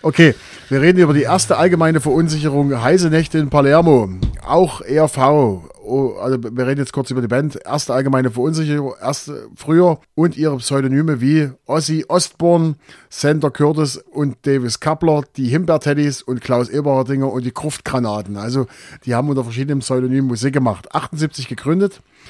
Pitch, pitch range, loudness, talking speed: 145 Hz, 130-155 Hz, -17 LUFS, 150 wpm